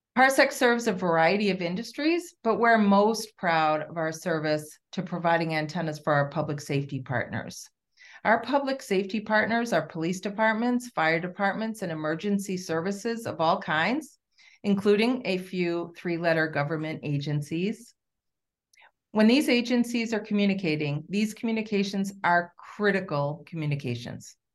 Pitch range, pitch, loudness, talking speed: 160-220 Hz, 185 Hz, -26 LUFS, 130 wpm